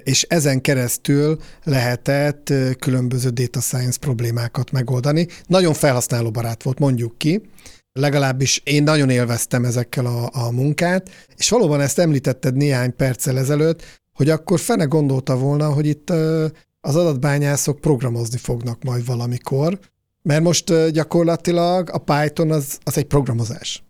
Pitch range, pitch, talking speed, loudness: 125-160 Hz, 145 Hz, 130 wpm, -19 LUFS